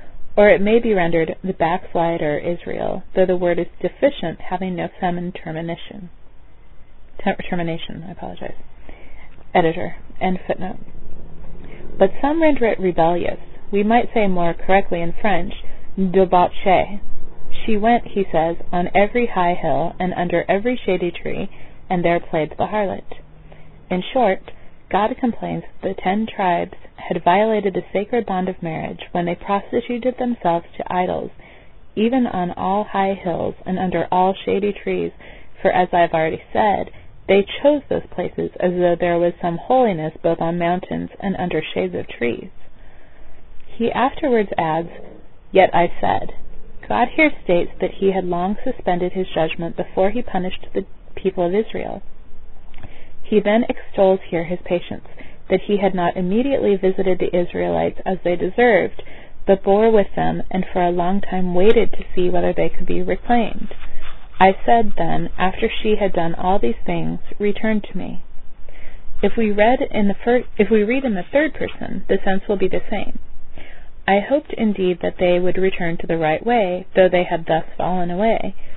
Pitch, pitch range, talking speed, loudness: 185 Hz, 170-210 Hz, 165 wpm, -20 LUFS